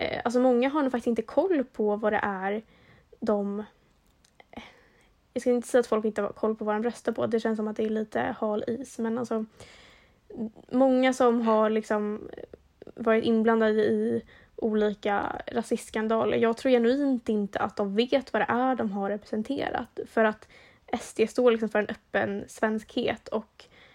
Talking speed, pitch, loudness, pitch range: 175 wpm, 225 Hz, -27 LUFS, 215-245 Hz